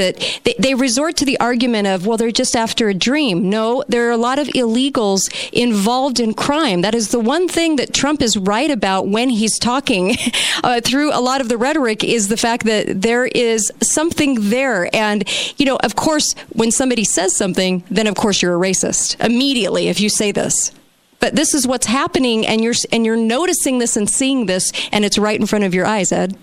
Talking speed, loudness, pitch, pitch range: 215 wpm, -15 LUFS, 235 Hz, 210-265 Hz